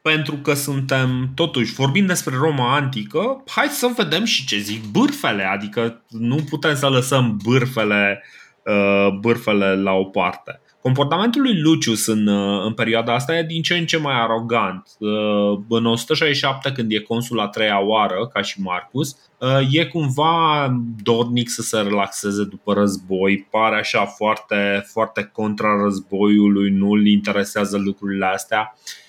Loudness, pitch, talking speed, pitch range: -19 LUFS, 115 Hz, 140 wpm, 100-140 Hz